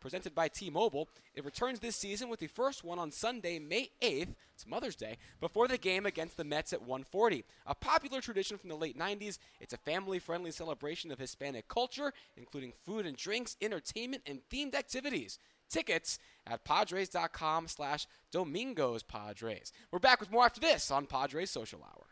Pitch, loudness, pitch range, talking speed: 180 Hz, -36 LUFS, 150-235 Hz, 175 wpm